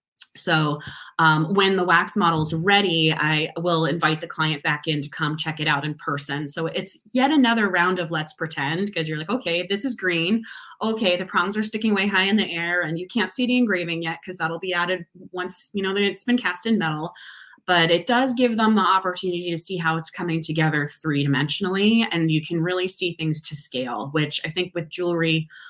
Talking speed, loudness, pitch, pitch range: 220 wpm, -22 LUFS, 175 Hz, 160-195 Hz